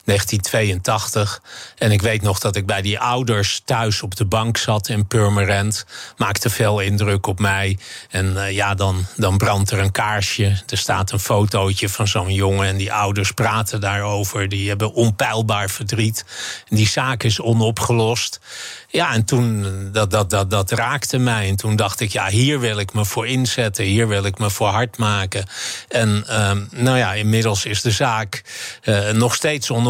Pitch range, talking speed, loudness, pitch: 100-115 Hz, 185 wpm, -19 LUFS, 105 Hz